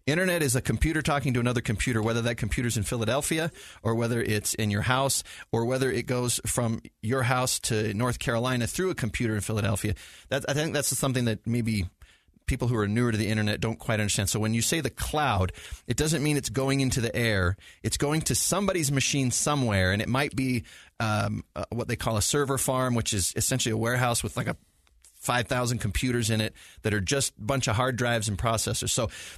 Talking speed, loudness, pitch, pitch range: 215 wpm, -27 LUFS, 120 Hz, 110-130 Hz